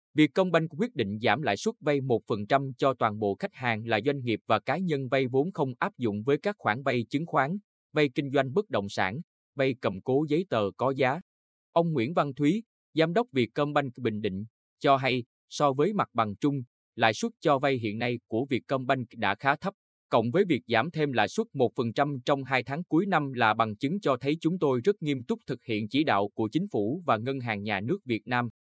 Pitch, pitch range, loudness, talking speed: 135 Hz, 115-155 Hz, -28 LUFS, 225 wpm